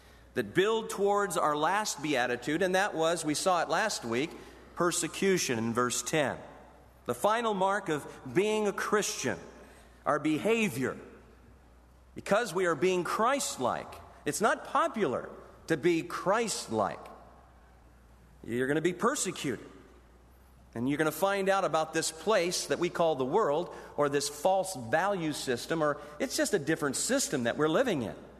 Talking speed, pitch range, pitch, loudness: 155 wpm, 125-190 Hz, 160 Hz, -30 LUFS